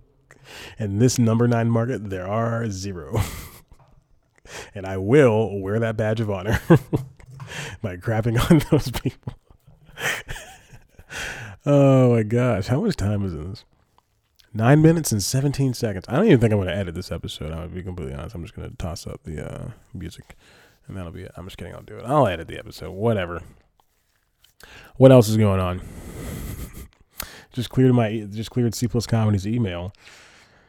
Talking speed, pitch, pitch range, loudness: 165 wpm, 110 Hz, 95-125 Hz, -21 LUFS